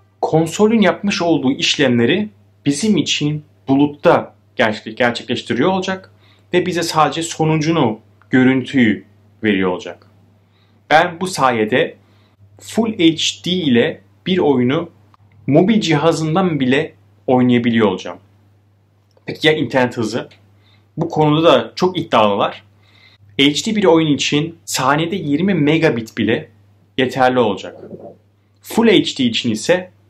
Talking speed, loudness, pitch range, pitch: 105 wpm, -16 LUFS, 105-160 Hz, 130 Hz